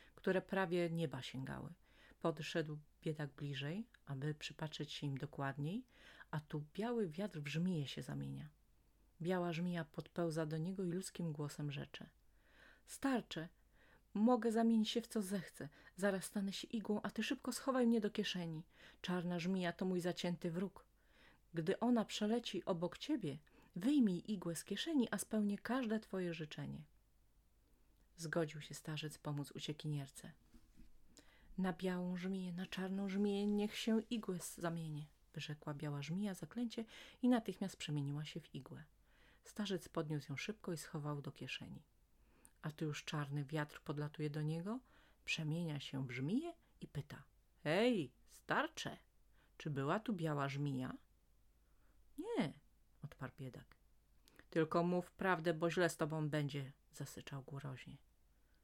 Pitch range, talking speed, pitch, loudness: 150-200 Hz, 135 wpm, 170 Hz, -42 LUFS